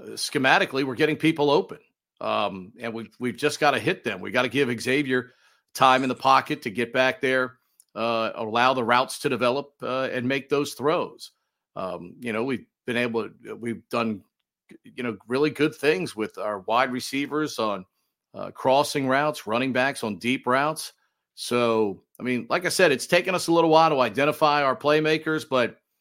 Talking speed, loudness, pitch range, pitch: 190 wpm, -24 LUFS, 120-150 Hz, 130 Hz